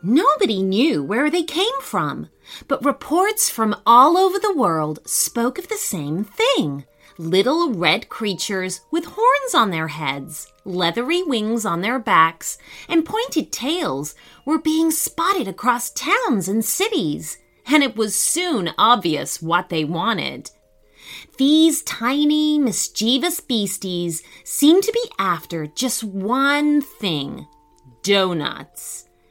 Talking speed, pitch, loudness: 125 wpm, 230 Hz, -19 LUFS